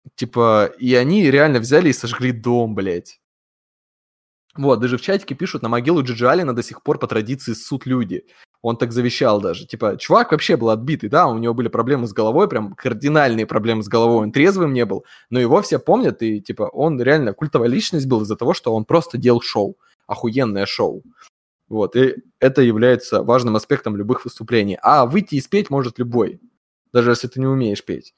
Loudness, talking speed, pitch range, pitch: -18 LUFS, 190 wpm, 115-140 Hz, 125 Hz